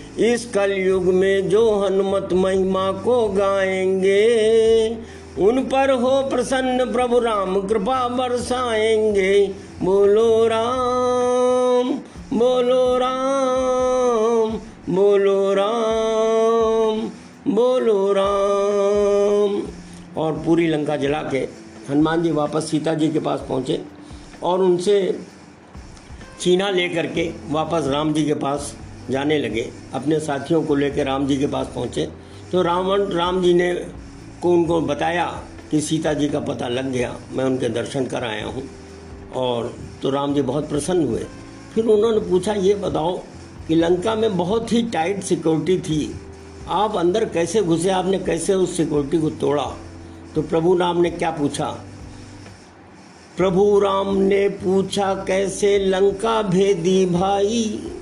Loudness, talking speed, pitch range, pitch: -20 LUFS, 125 wpm, 150-220 Hz, 190 Hz